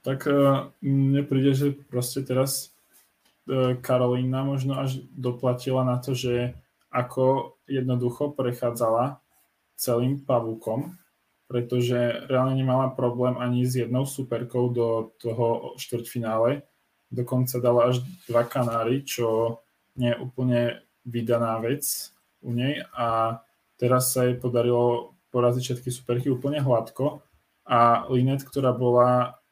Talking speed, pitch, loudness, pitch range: 115 wpm, 125 Hz, -25 LUFS, 120-135 Hz